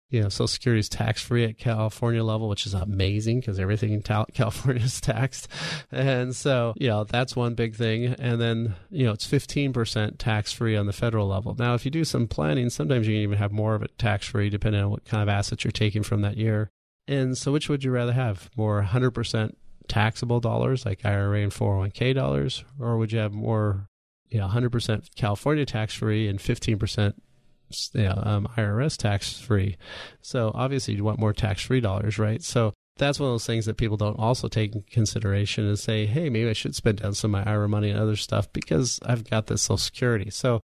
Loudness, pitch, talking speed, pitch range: -26 LUFS, 110 Hz, 215 wpm, 105-120 Hz